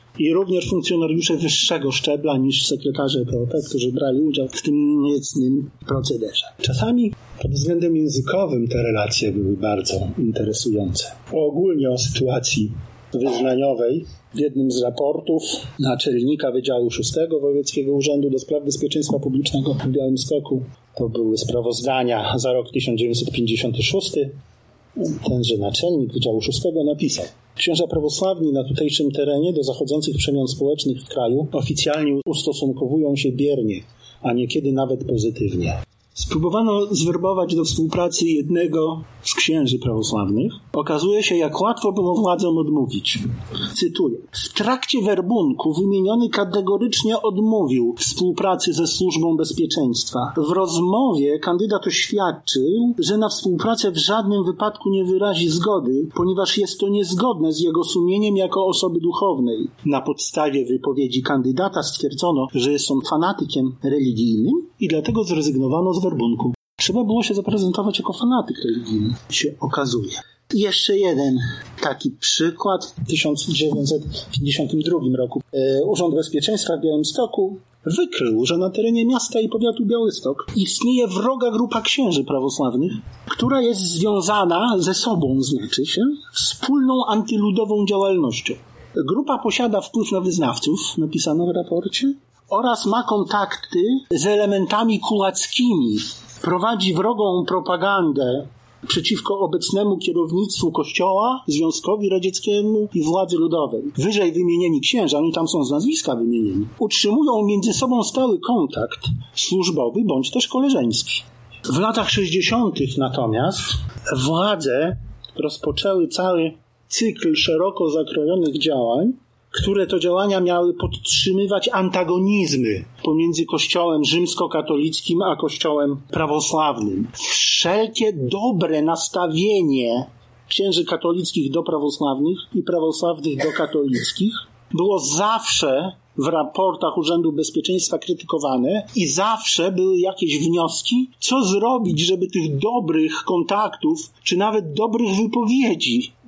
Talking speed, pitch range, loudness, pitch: 115 wpm, 140-205 Hz, -20 LUFS, 170 Hz